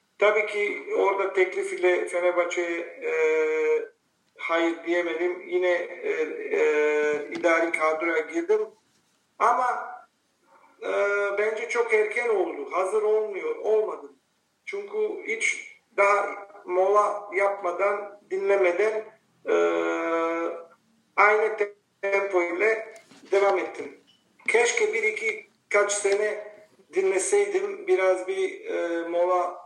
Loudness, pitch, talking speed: -25 LUFS, 210 Hz, 95 wpm